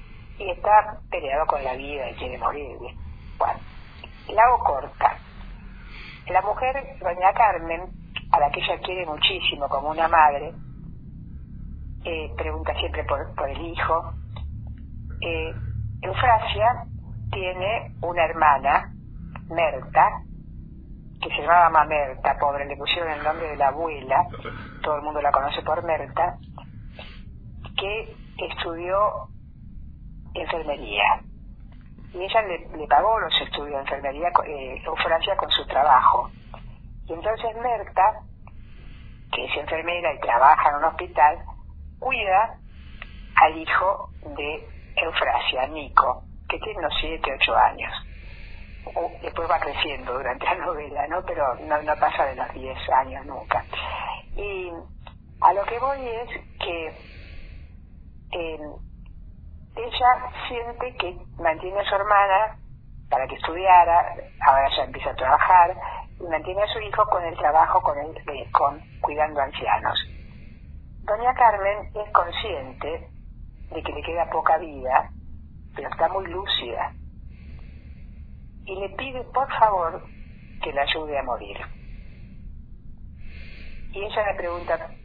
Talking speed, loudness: 130 wpm, -23 LUFS